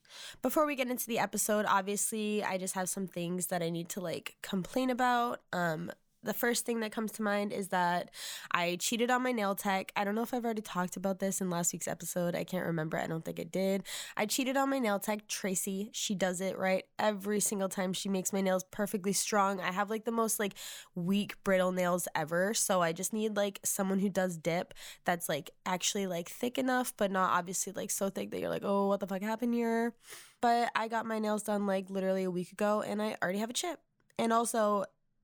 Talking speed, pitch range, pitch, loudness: 230 wpm, 185-220 Hz, 200 Hz, -33 LUFS